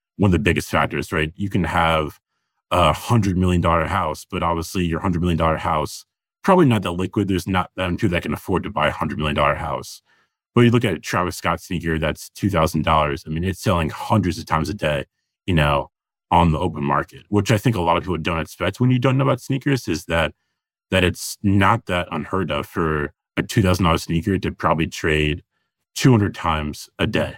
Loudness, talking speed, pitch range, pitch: -20 LUFS, 230 wpm, 80-100 Hz, 90 Hz